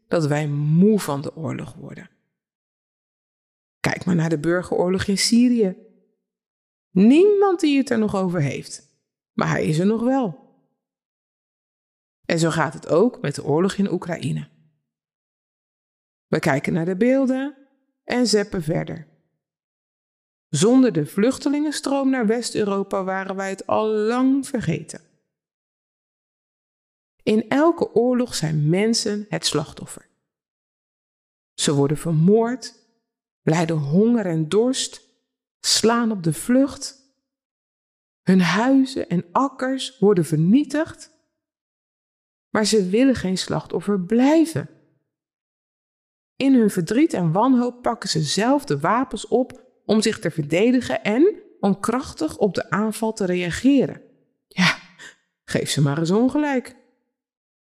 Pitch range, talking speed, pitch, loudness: 170-255 Hz, 120 wpm, 215 Hz, -20 LUFS